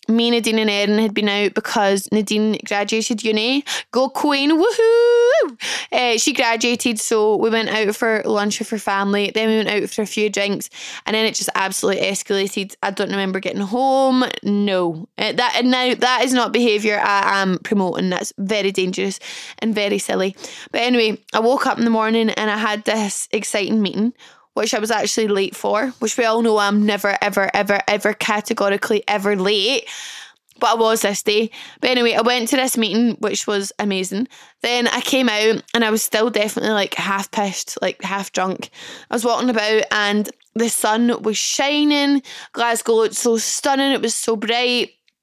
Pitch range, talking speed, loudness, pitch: 205-240 Hz, 190 wpm, -18 LUFS, 220 Hz